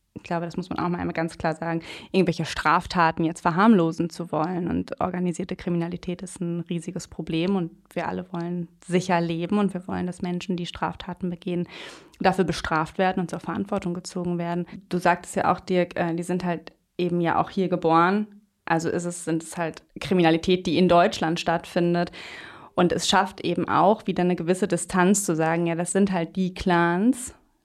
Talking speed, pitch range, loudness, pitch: 190 wpm, 170-185 Hz, -25 LUFS, 175 Hz